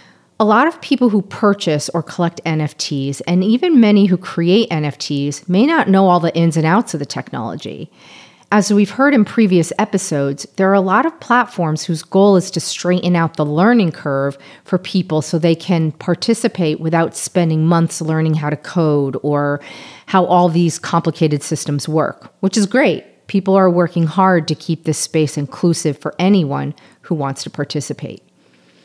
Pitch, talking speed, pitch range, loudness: 170 Hz, 175 wpm, 150-195 Hz, -16 LUFS